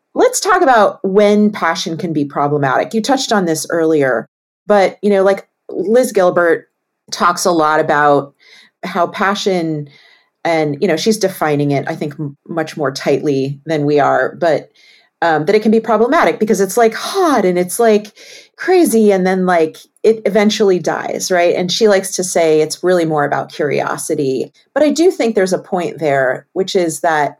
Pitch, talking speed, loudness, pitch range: 180 Hz, 180 wpm, -14 LUFS, 155-210 Hz